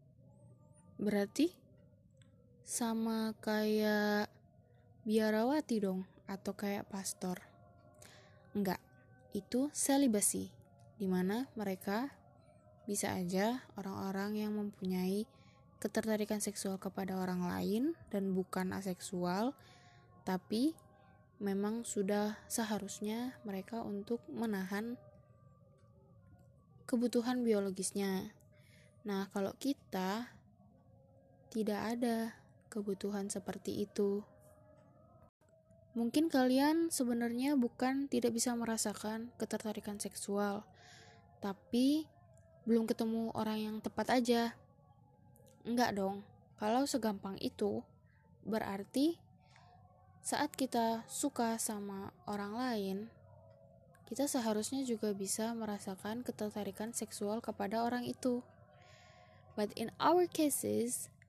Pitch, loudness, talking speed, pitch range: 210 Hz, -37 LUFS, 85 wpm, 195-230 Hz